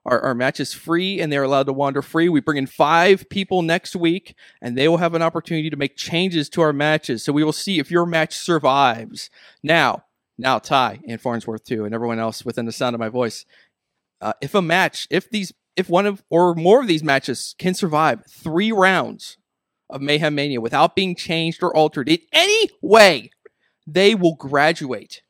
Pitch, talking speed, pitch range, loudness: 160 Hz, 200 wpm, 135-175 Hz, -19 LUFS